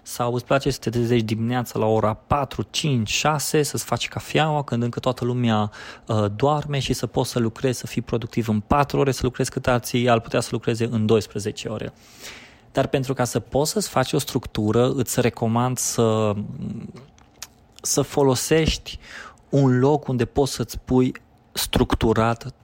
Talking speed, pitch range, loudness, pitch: 170 wpm, 115-135 Hz, -22 LUFS, 125 Hz